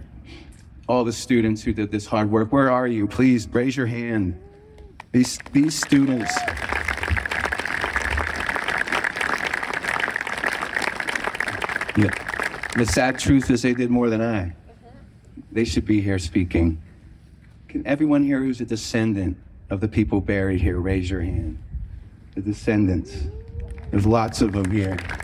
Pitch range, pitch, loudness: 90-120 Hz, 105 Hz, -22 LUFS